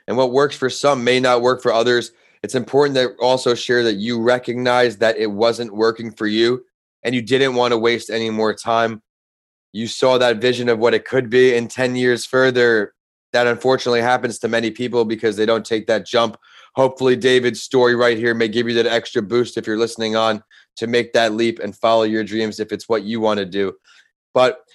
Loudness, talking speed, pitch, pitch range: -18 LUFS, 215 wpm, 120 Hz, 115-125 Hz